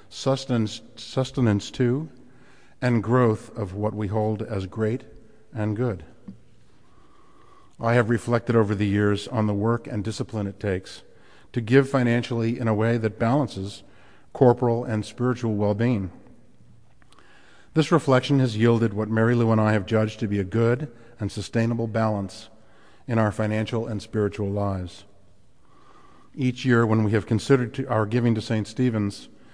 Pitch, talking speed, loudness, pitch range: 115 Hz, 150 wpm, -24 LUFS, 105-120 Hz